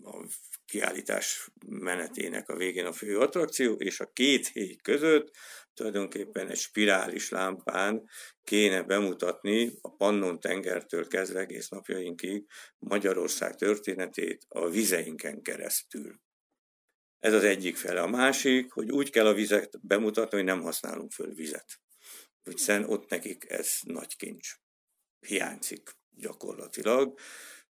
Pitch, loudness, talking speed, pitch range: 105 Hz, -30 LUFS, 115 wpm, 95-110 Hz